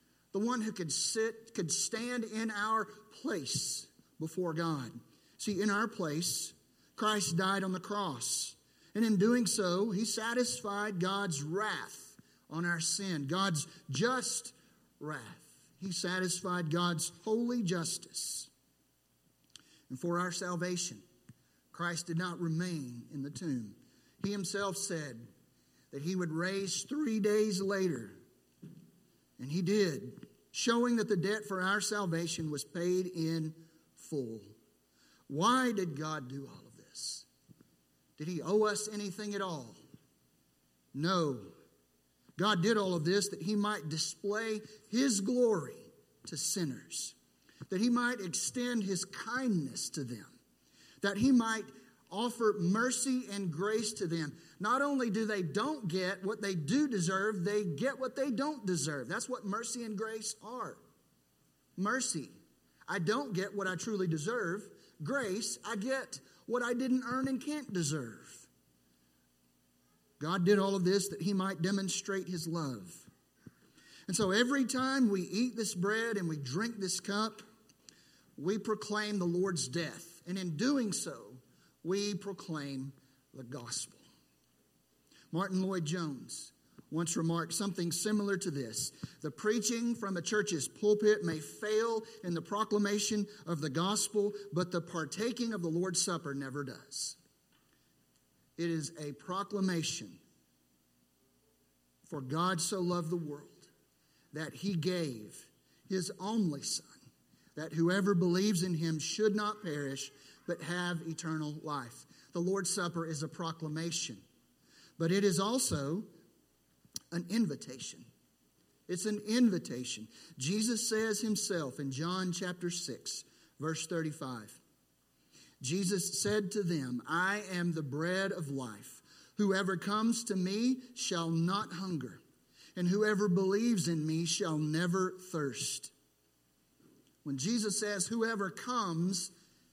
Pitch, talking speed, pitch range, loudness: 185 Hz, 135 wpm, 155-210 Hz, -35 LUFS